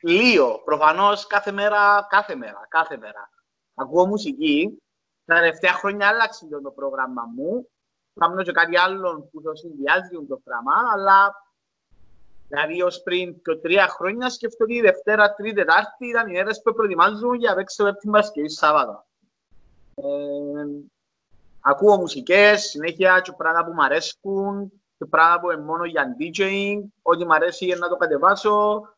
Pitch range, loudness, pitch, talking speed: 165-210 Hz, -20 LUFS, 190 Hz, 155 wpm